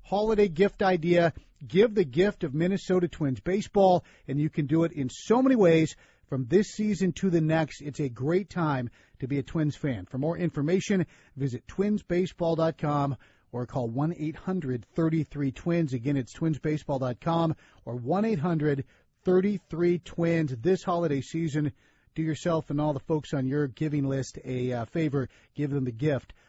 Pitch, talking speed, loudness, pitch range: 155 Hz, 165 wpm, -28 LUFS, 135-175 Hz